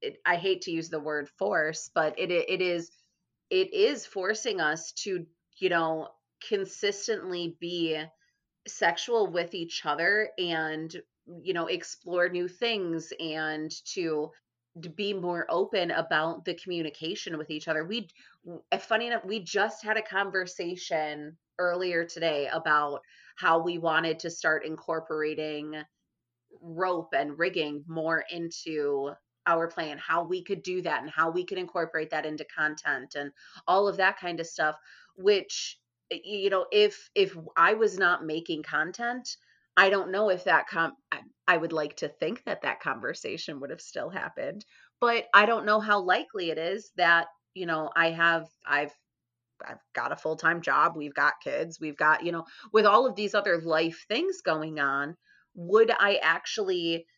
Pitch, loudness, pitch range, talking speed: 170 Hz, -28 LUFS, 155-195 Hz, 160 wpm